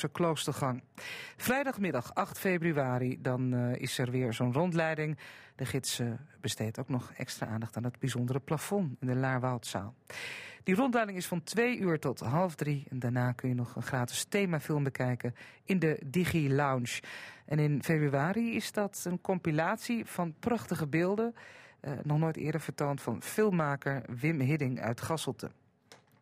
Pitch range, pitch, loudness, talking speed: 130-180 Hz, 150 Hz, -33 LUFS, 160 wpm